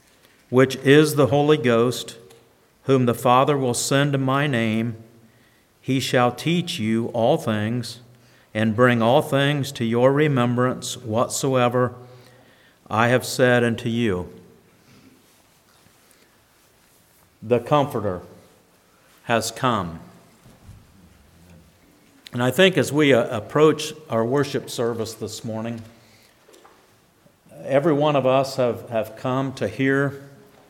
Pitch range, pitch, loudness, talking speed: 115-135 Hz, 120 Hz, -21 LUFS, 110 wpm